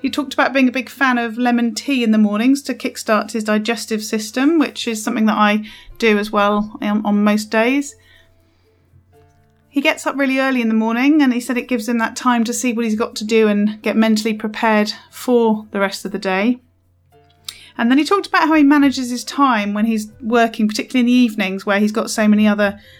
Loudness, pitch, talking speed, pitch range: -17 LUFS, 225 Hz, 220 wpm, 210-255 Hz